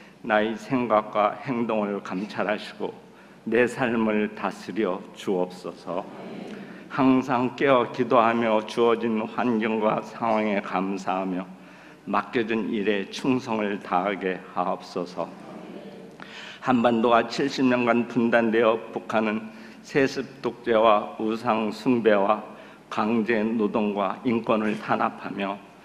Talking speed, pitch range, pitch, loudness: 220 characters per minute, 100-120 Hz, 110 Hz, -25 LUFS